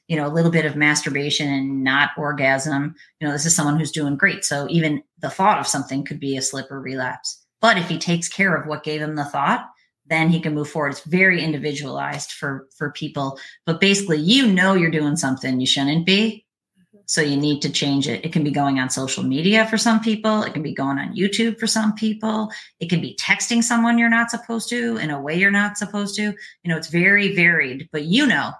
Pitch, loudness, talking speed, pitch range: 155 Hz, -20 LUFS, 235 wpm, 145-200 Hz